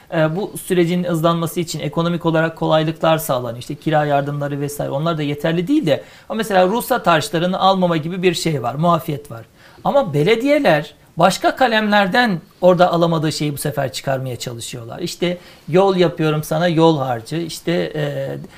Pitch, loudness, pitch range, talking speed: 165 Hz, -18 LUFS, 150-180 Hz, 155 wpm